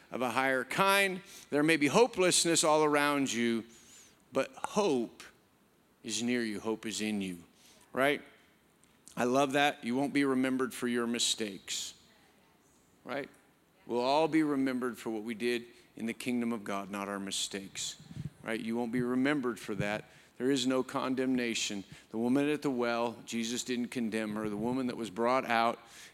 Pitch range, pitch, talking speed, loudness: 115-140 Hz, 120 Hz, 170 wpm, -32 LUFS